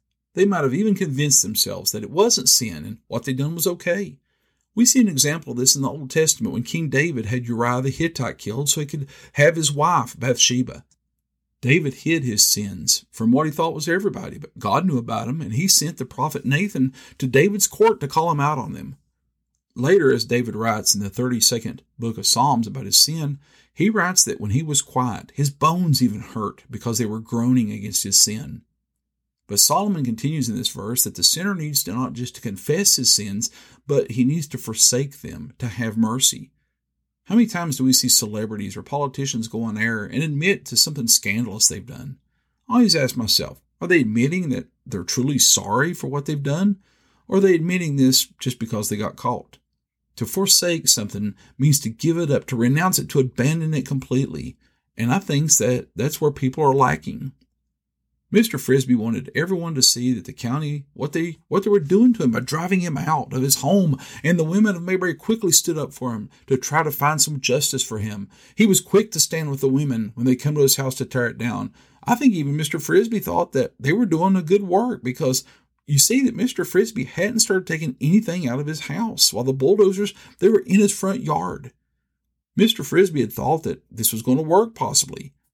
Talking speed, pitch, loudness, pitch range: 215 wpm, 135 Hz, -19 LUFS, 120-165 Hz